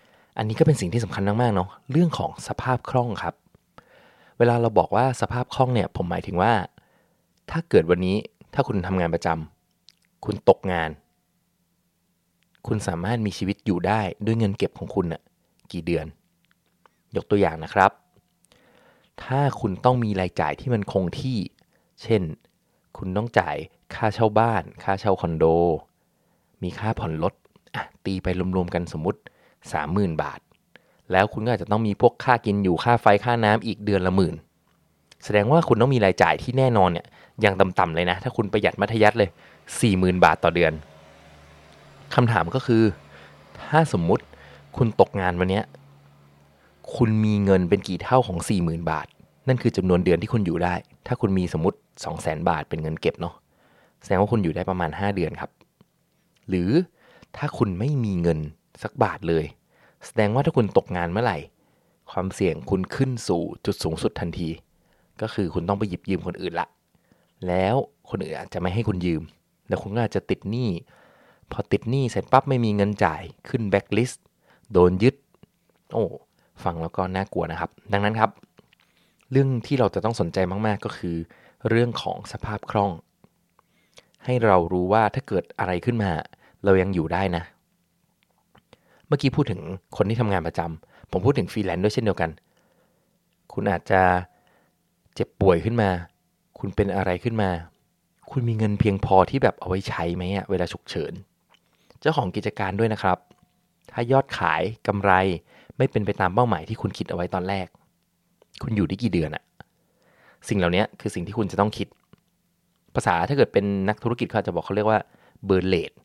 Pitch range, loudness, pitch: 90-115 Hz, -24 LUFS, 100 Hz